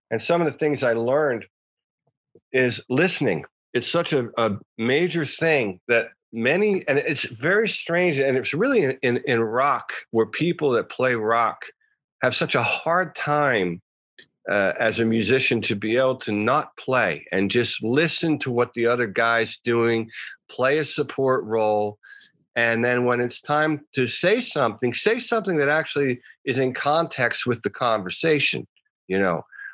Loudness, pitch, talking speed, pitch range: -22 LUFS, 130 Hz, 160 wpm, 115-160 Hz